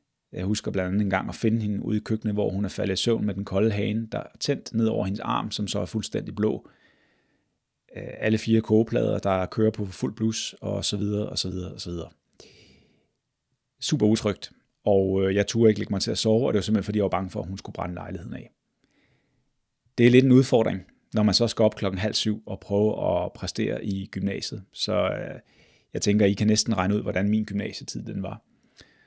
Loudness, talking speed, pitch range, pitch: -25 LUFS, 225 wpm, 100-110 Hz, 105 Hz